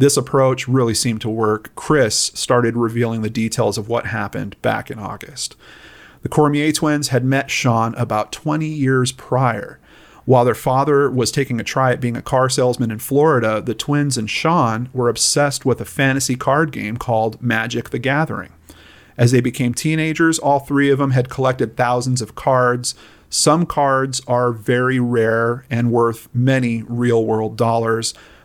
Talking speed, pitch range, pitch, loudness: 170 wpm, 115-135 Hz, 125 Hz, -18 LUFS